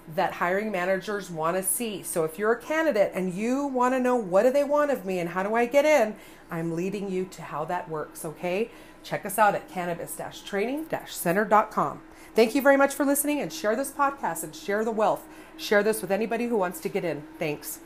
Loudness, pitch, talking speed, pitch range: -26 LUFS, 205 Hz, 220 wpm, 175-250 Hz